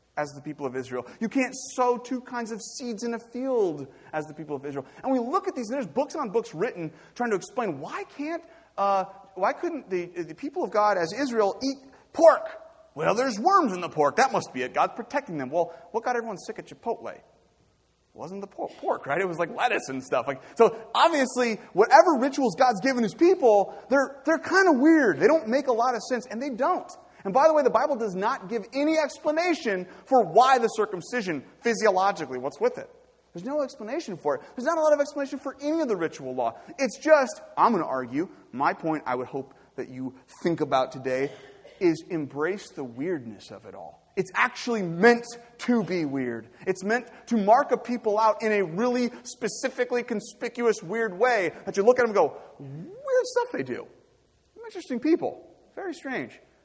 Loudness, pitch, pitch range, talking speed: -26 LUFS, 235 Hz, 185-280 Hz, 210 wpm